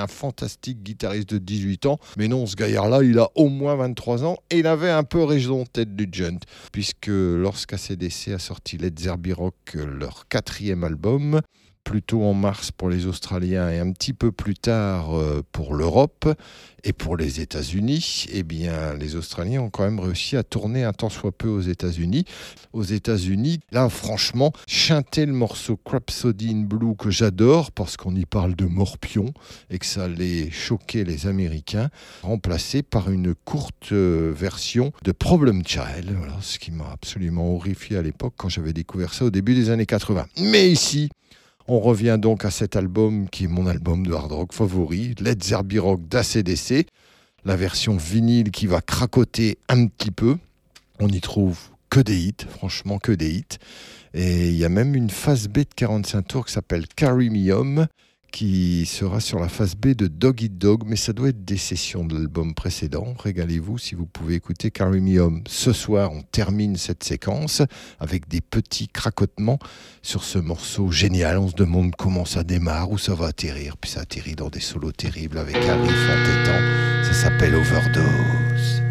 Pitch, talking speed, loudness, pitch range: 100 Hz, 180 wpm, -22 LUFS, 90-120 Hz